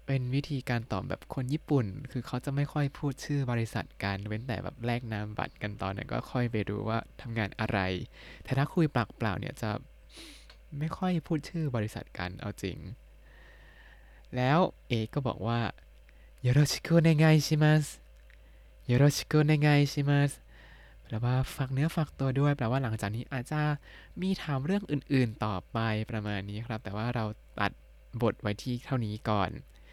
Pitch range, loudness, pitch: 105-145 Hz, -31 LUFS, 125 Hz